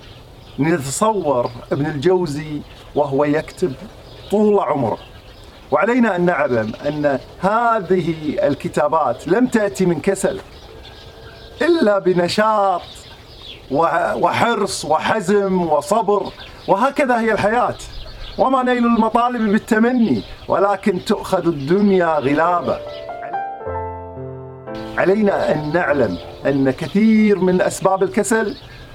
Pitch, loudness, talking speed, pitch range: 190 Hz, -18 LUFS, 85 wpm, 145-215 Hz